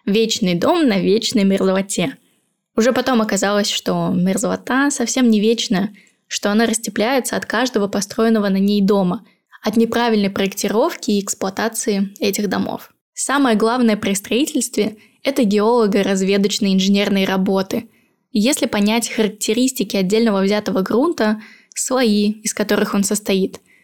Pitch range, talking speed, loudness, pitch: 200-230 Hz, 125 wpm, -17 LUFS, 215 Hz